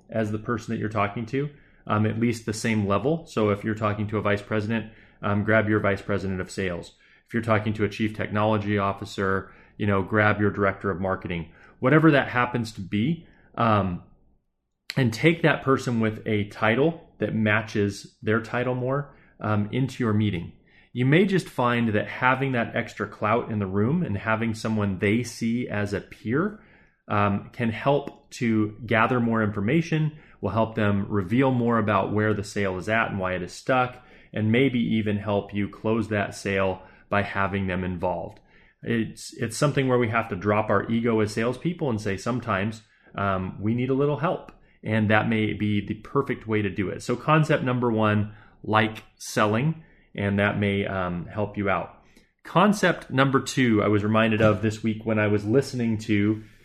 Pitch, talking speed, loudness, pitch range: 110 Hz, 190 wpm, -25 LUFS, 100-120 Hz